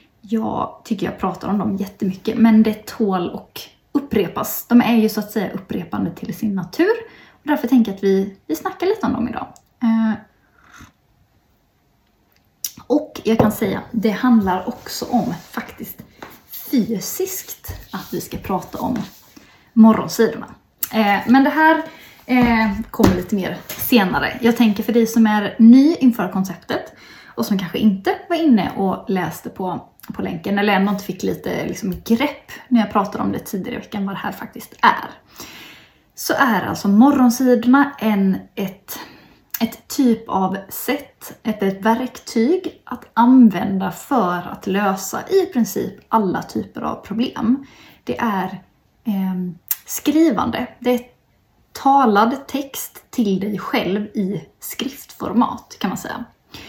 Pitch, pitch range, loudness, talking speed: 225 Hz, 200-250 Hz, -19 LUFS, 150 wpm